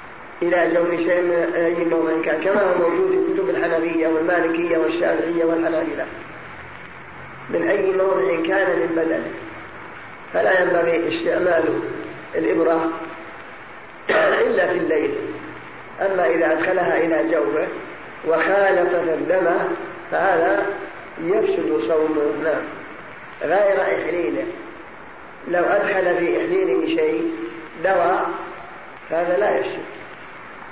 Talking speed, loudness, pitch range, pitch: 100 wpm, -20 LUFS, 165-190 Hz, 170 Hz